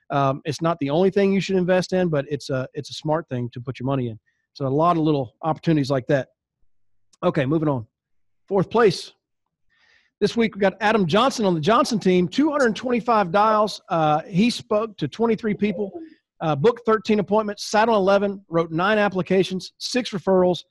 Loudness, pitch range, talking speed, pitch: -21 LUFS, 150-210 Hz, 190 wpm, 185 Hz